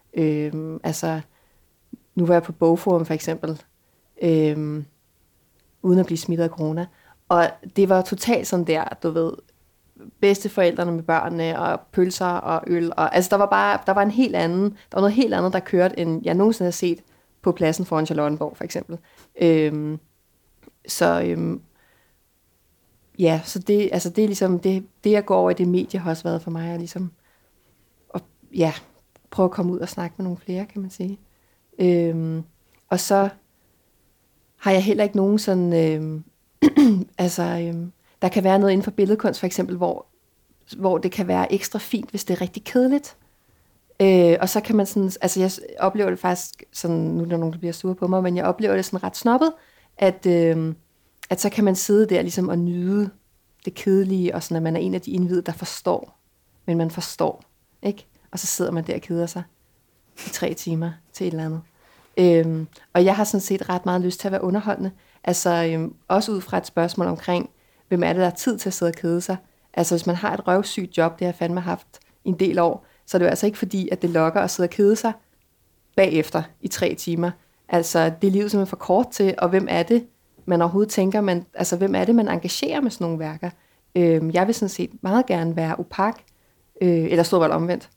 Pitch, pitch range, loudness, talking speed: 180 Hz, 165-195 Hz, -22 LUFS, 210 wpm